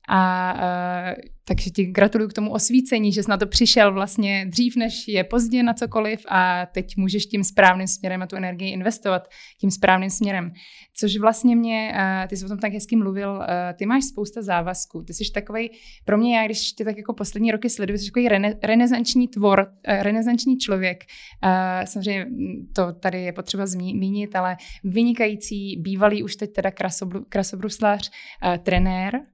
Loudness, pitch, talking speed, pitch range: -22 LUFS, 205 Hz, 175 wpm, 185-220 Hz